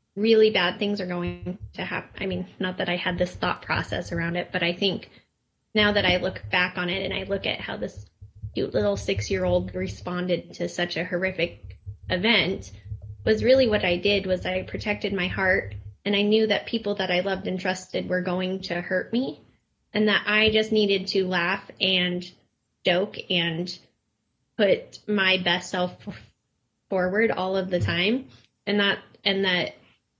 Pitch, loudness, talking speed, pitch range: 185 Hz, -25 LUFS, 180 wpm, 175-200 Hz